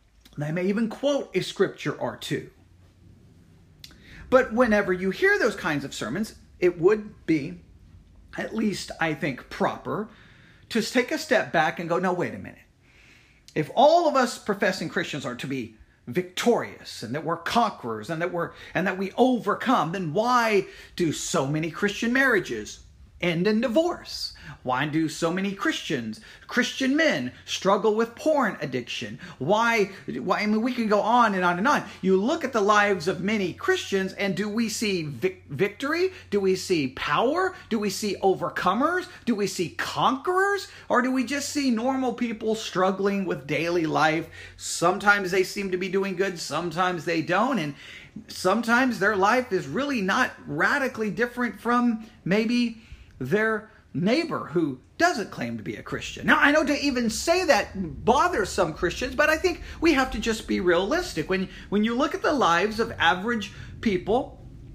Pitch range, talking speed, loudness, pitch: 170-245 Hz, 170 wpm, -25 LUFS, 200 Hz